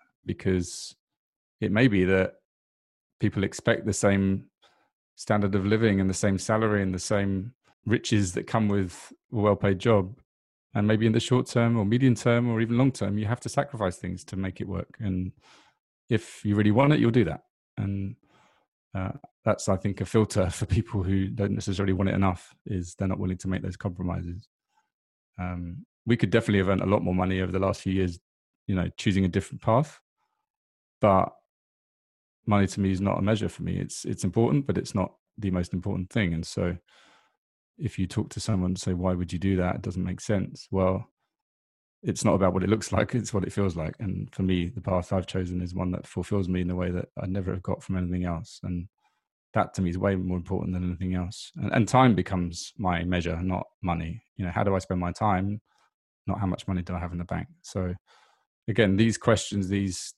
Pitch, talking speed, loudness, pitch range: 95 Hz, 215 wpm, -27 LUFS, 90-105 Hz